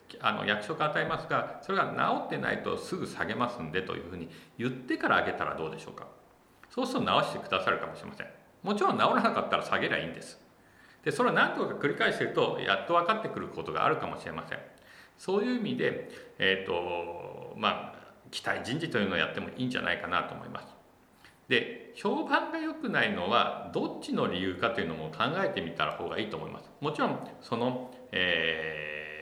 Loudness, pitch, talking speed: -31 LUFS, 195 Hz, 425 characters per minute